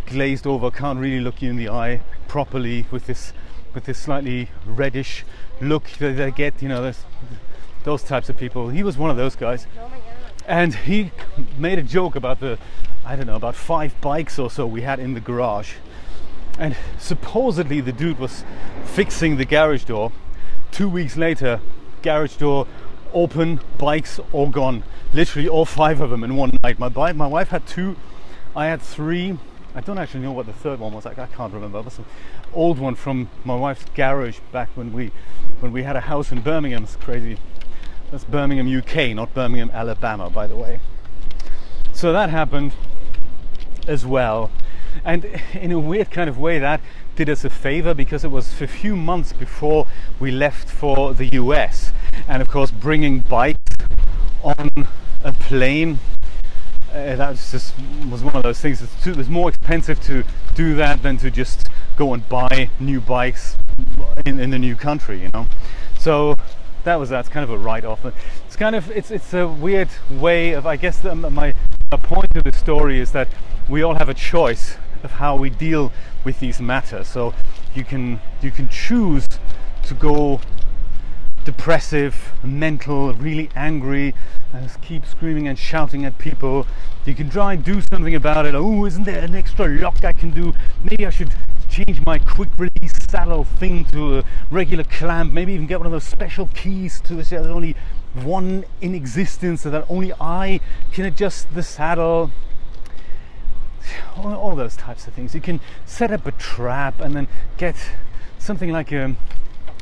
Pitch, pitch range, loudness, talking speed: 140 Hz, 120-160 Hz, -22 LUFS, 180 wpm